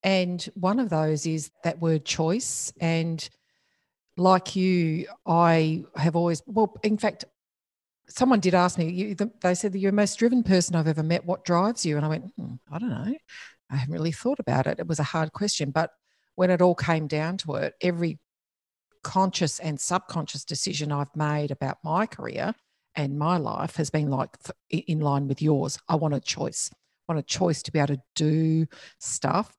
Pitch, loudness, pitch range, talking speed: 165 Hz, -26 LUFS, 155-185 Hz, 195 wpm